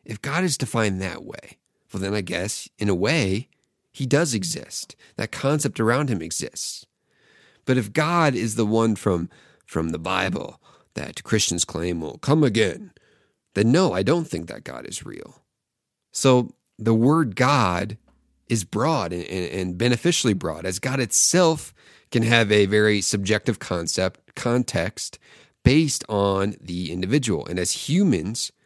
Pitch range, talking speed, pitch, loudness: 95-130 Hz, 155 wpm, 110 Hz, -22 LUFS